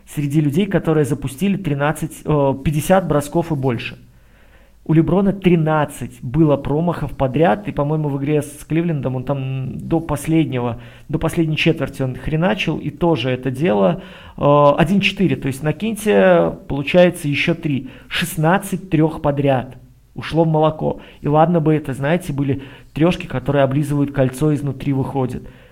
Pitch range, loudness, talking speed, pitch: 135-165 Hz, -18 LUFS, 140 wpm, 150 Hz